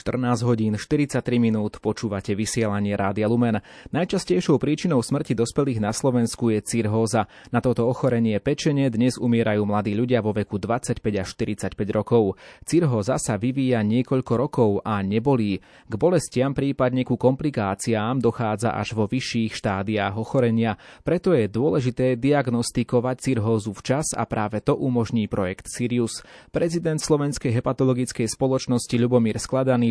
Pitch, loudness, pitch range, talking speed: 120 Hz, -23 LUFS, 110-130 Hz, 130 wpm